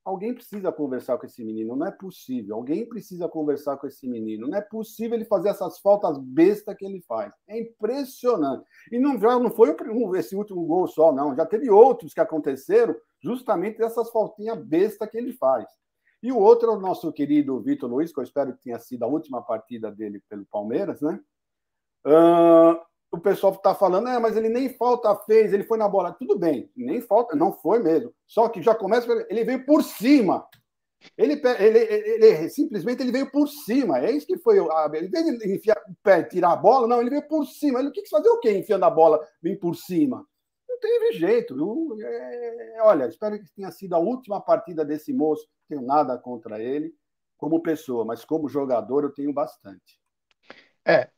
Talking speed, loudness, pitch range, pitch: 200 wpm, -22 LUFS, 160-255 Hz, 210 Hz